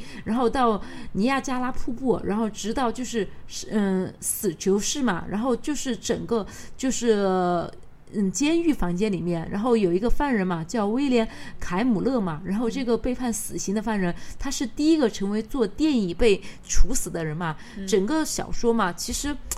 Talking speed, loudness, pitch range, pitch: 255 characters per minute, -25 LUFS, 190-250 Hz, 225 Hz